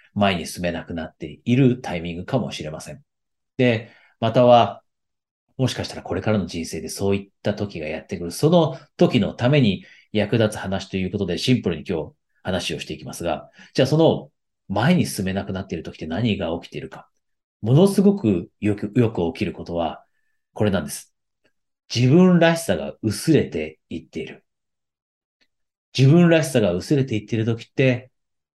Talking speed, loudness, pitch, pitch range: 345 characters per minute, -21 LUFS, 115 Hz, 95-130 Hz